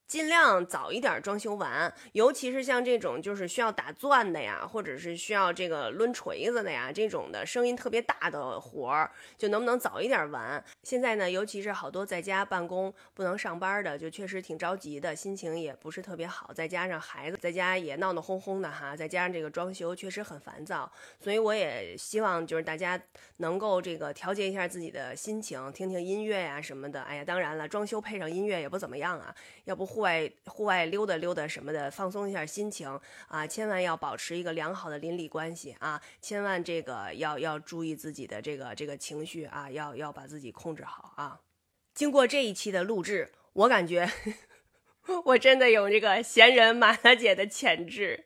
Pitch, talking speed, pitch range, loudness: 185 Hz, 310 characters per minute, 160-210 Hz, -29 LUFS